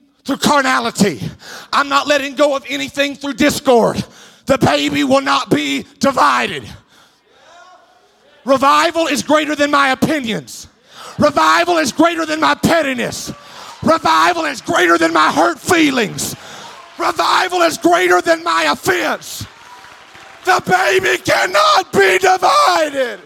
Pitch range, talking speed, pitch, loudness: 265-330 Hz, 120 wpm, 290 Hz, -14 LUFS